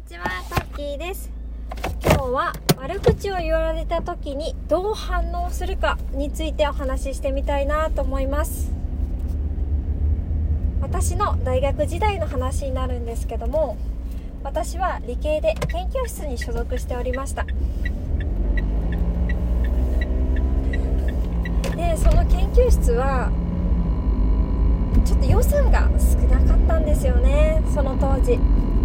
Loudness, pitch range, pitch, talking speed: -23 LUFS, 65-90 Hz, 80 Hz, 230 characters per minute